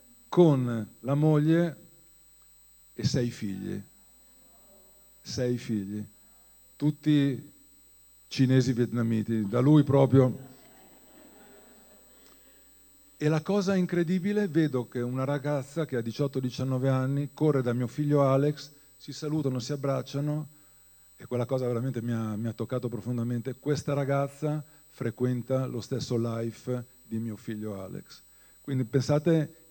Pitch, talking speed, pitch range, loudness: 135 Hz, 115 wpm, 120-150 Hz, -28 LUFS